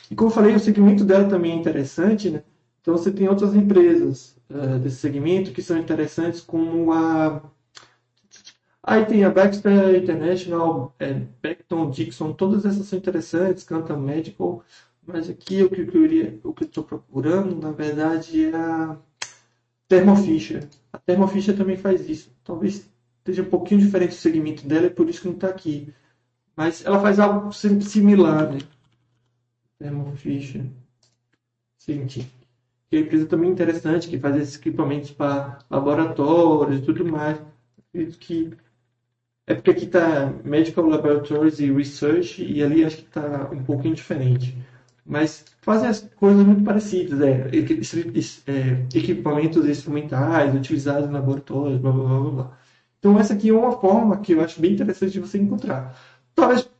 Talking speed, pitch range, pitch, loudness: 145 wpm, 140-185 Hz, 160 Hz, -20 LUFS